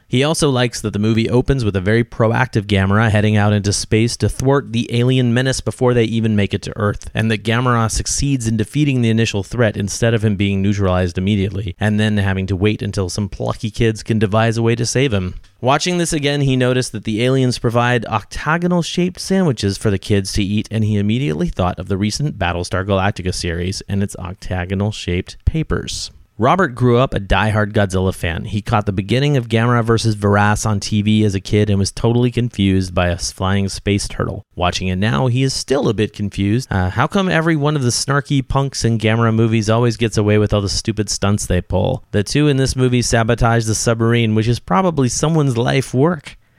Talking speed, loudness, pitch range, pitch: 215 wpm, -17 LUFS, 100-125 Hz, 110 Hz